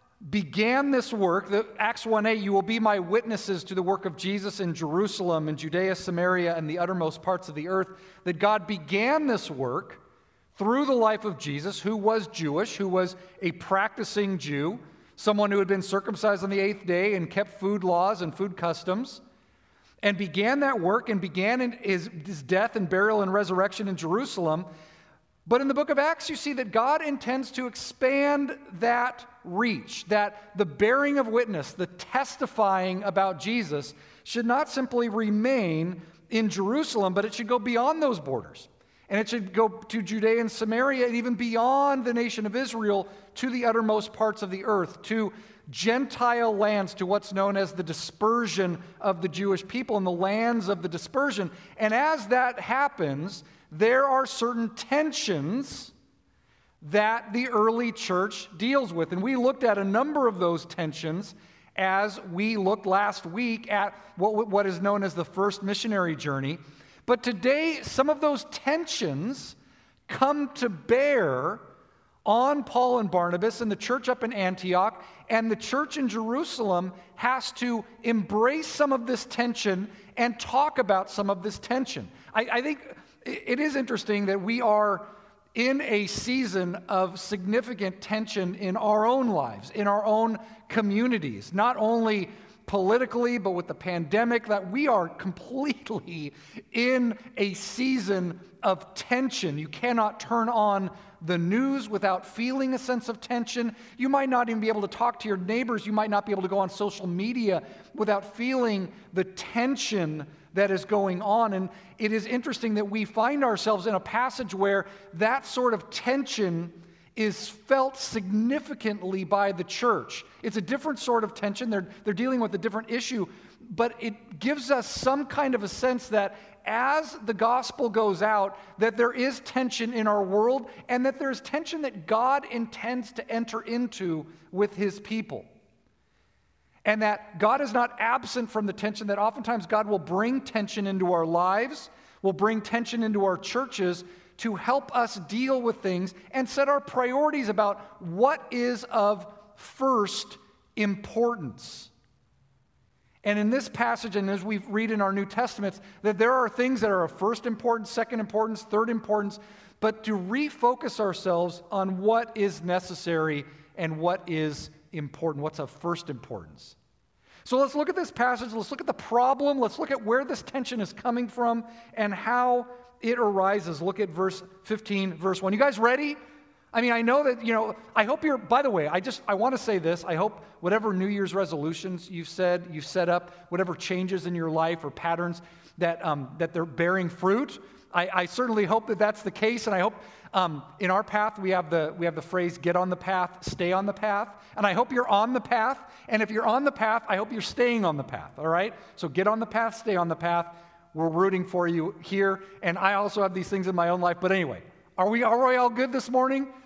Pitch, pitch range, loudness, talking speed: 210 Hz, 190-240 Hz, -27 LUFS, 180 wpm